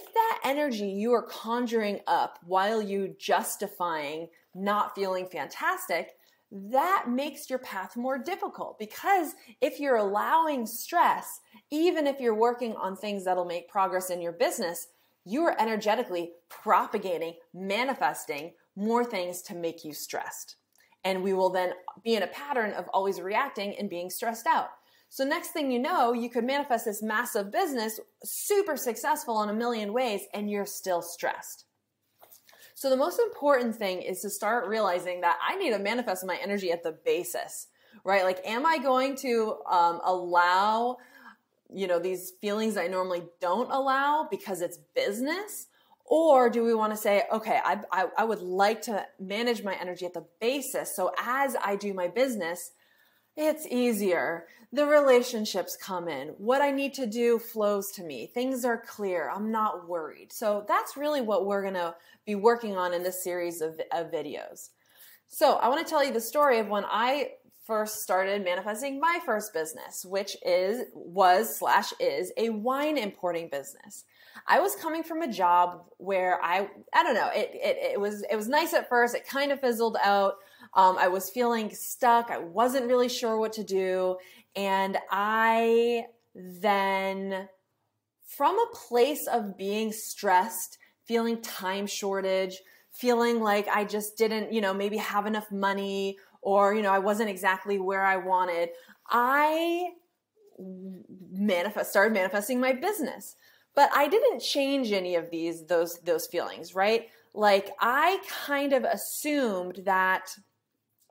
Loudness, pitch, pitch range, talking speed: -28 LUFS, 215 Hz, 190-260 Hz, 160 wpm